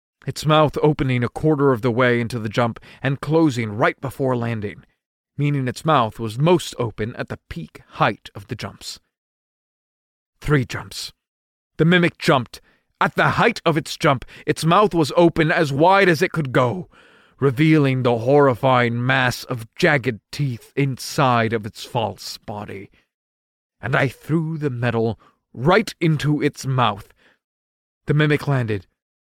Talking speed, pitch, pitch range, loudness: 150 wpm, 135 Hz, 120-155 Hz, -19 LUFS